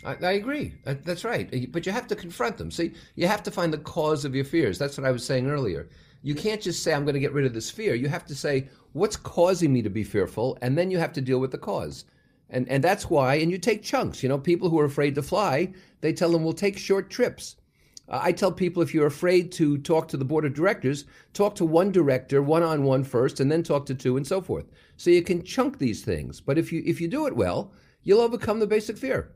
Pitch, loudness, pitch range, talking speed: 160 Hz, -25 LUFS, 140-180 Hz, 265 wpm